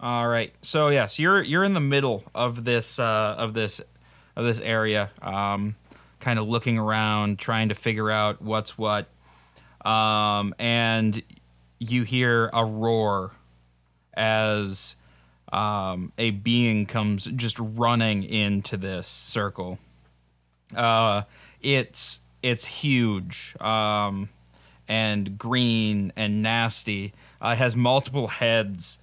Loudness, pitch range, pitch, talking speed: -24 LUFS, 100-115 Hz, 110 Hz, 120 wpm